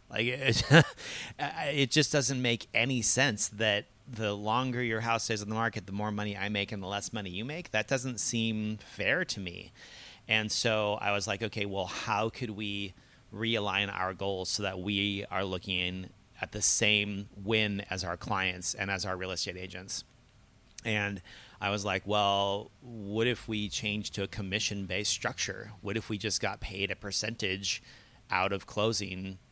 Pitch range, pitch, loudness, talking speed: 100-110 Hz, 105 Hz, -30 LUFS, 180 wpm